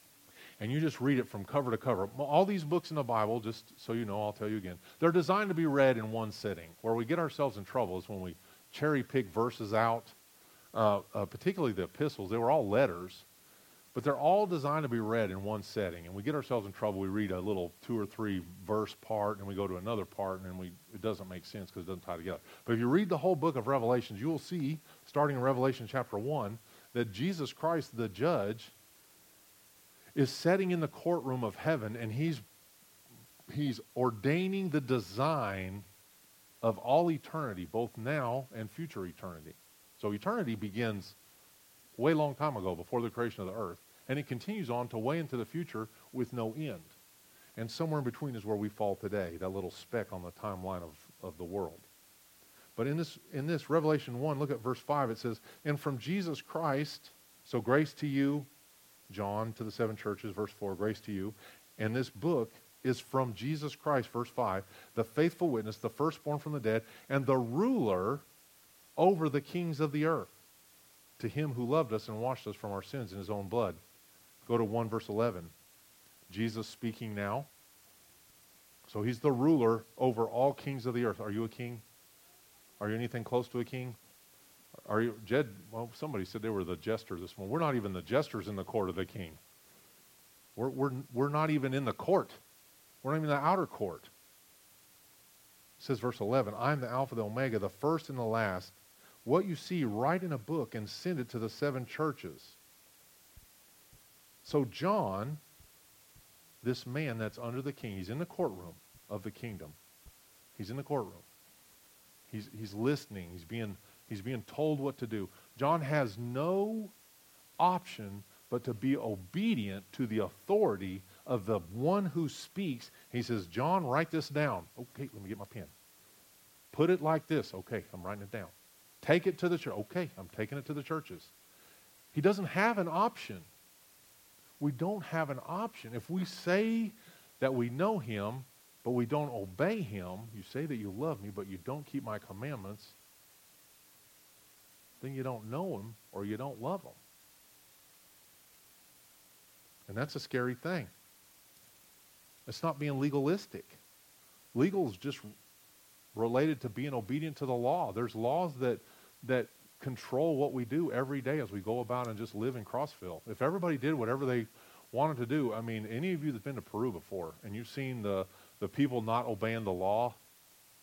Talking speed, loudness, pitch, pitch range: 190 wpm, -35 LUFS, 120 Hz, 105-145 Hz